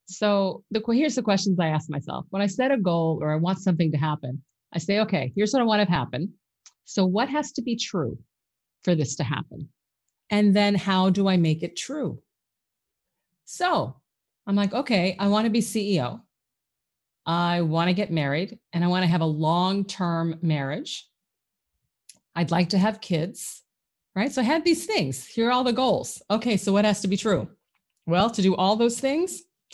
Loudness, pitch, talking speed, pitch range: -24 LUFS, 190 Hz, 195 wpm, 165-220 Hz